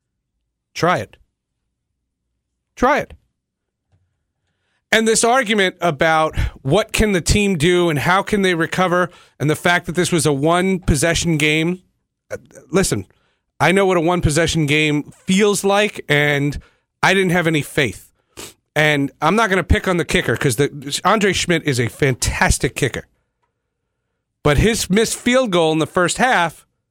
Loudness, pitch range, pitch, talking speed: -17 LUFS, 145-190 Hz, 170 Hz, 155 wpm